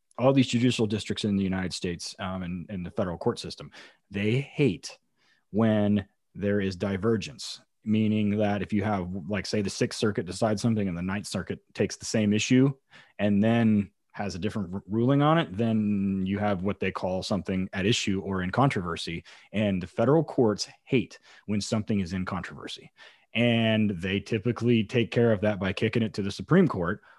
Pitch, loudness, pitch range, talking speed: 105 Hz, -27 LUFS, 95-115 Hz, 190 wpm